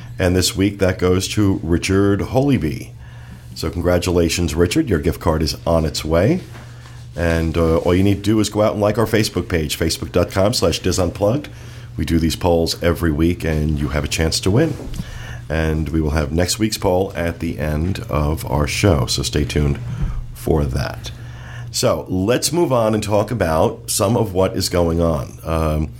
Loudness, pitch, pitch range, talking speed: -18 LUFS, 90 Hz, 80-110 Hz, 185 wpm